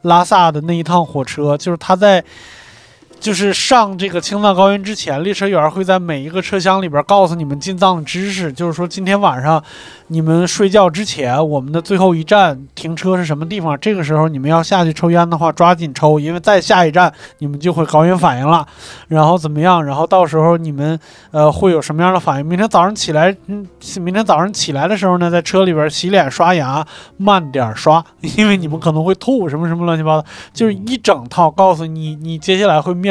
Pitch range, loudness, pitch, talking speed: 155-190 Hz, -13 LUFS, 175 Hz, 330 characters per minute